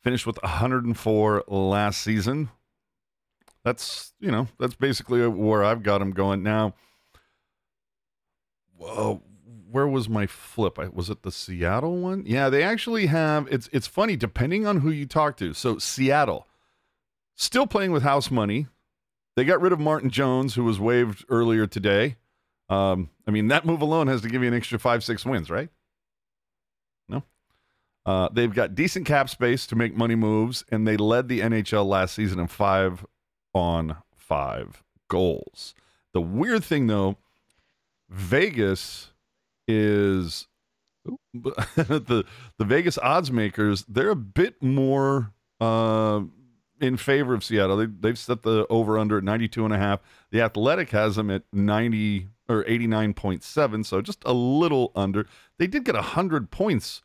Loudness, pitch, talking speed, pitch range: -24 LUFS, 115 Hz, 155 wpm, 105-135 Hz